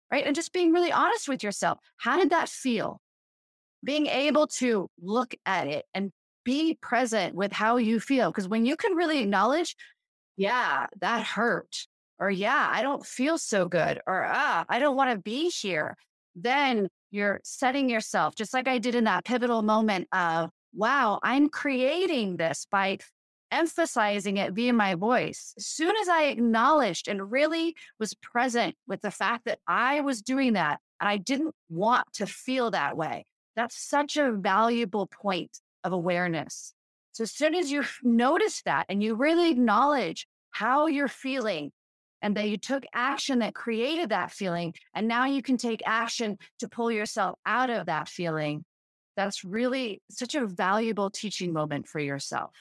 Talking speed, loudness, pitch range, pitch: 170 wpm, -27 LUFS, 200-275 Hz, 235 Hz